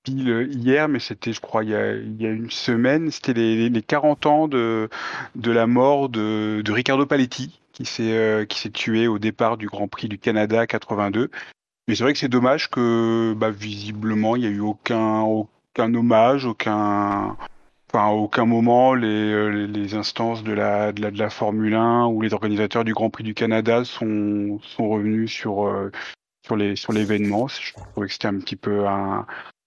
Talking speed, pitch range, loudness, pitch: 200 wpm, 105-120 Hz, -21 LUFS, 110 Hz